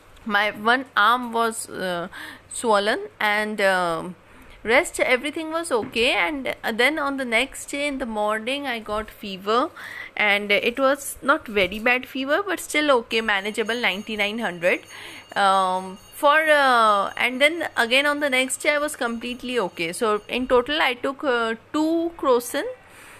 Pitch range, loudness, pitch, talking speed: 210-285 Hz, -22 LUFS, 240 Hz, 150 wpm